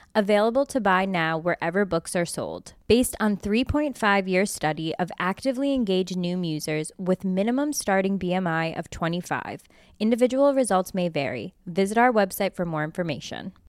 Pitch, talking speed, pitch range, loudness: 190 Hz, 150 wpm, 175-215 Hz, -24 LUFS